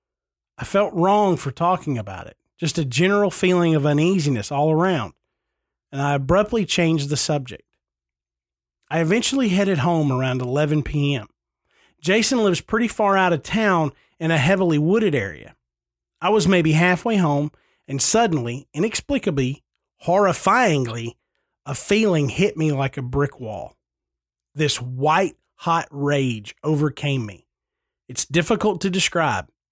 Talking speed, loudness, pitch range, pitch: 135 wpm, -20 LUFS, 135-190 Hz, 155 Hz